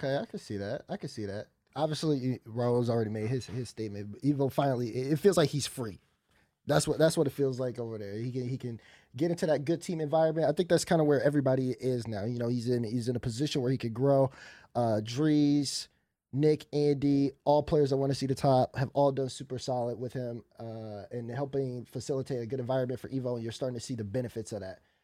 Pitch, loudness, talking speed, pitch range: 130 Hz, -31 LUFS, 240 wpm, 120-145 Hz